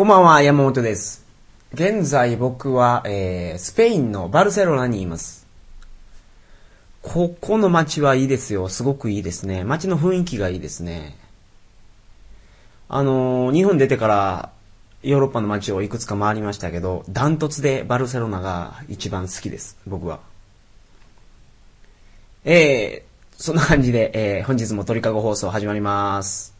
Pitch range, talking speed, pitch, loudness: 95-135 Hz, 290 characters per minute, 105 Hz, -19 LUFS